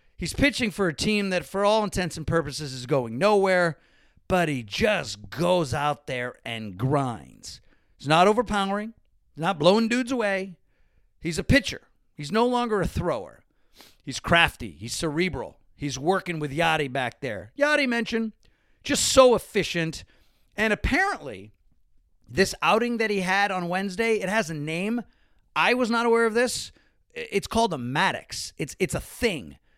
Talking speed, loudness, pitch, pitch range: 160 wpm, -24 LUFS, 185 Hz, 150-220 Hz